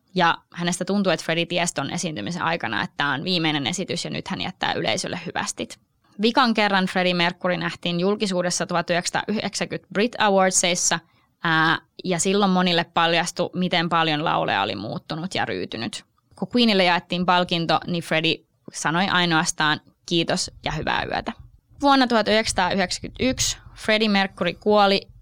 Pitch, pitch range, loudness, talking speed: 175 Hz, 165-195 Hz, -22 LUFS, 135 wpm